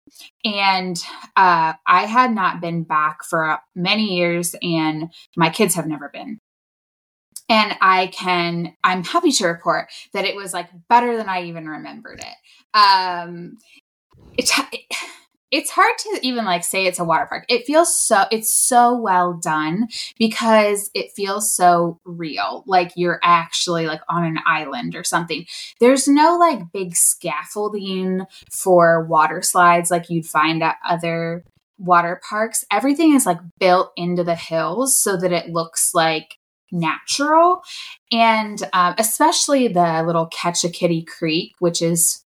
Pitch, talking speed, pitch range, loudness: 180 Hz, 150 wpm, 170-230 Hz, -18 LUFS